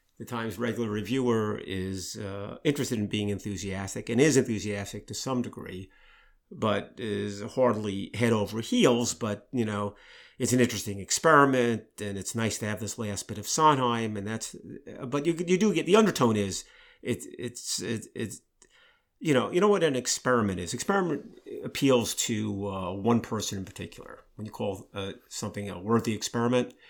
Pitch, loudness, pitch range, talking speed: 110 Hz, -28 LUFS, 100-125 Hz, 170 wpm